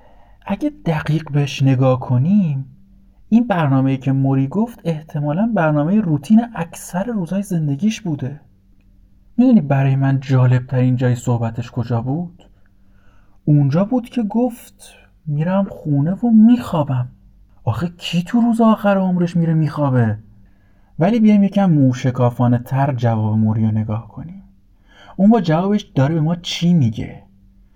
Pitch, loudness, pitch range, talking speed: 140 Hz, -17 LUFS, 115-185 Hz, 130 wpm